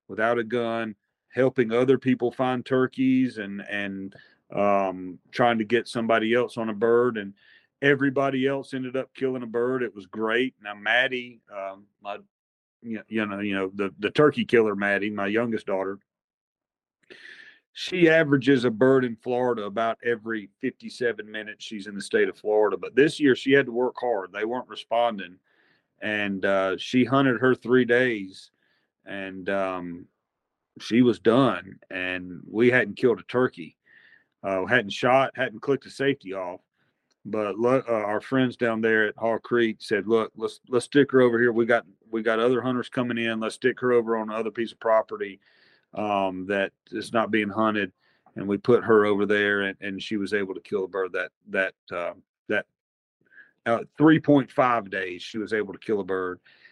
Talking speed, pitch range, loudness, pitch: 180 wpm, 100-125 Hz, -25 LUFS, 115 Hz